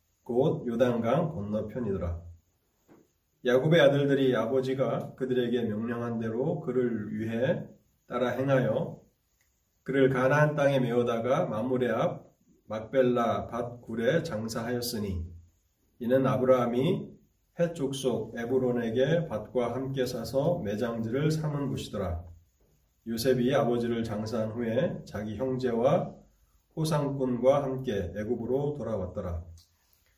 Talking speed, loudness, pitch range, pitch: 255 characters per minute, -29 LUFS, 110-130 Hz, 120 Hz